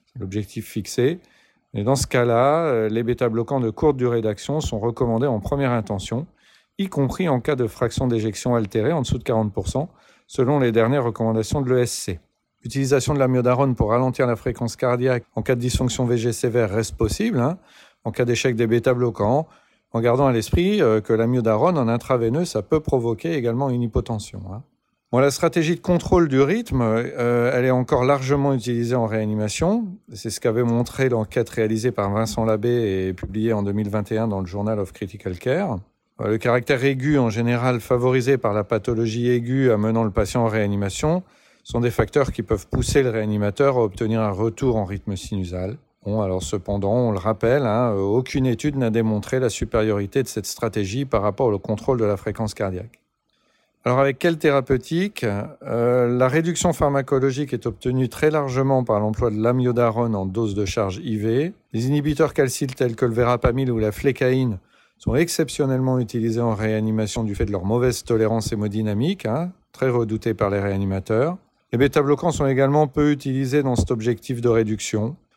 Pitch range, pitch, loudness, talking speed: 110-135 Hz, 120 Hz, -21 LUFS, 180 wpm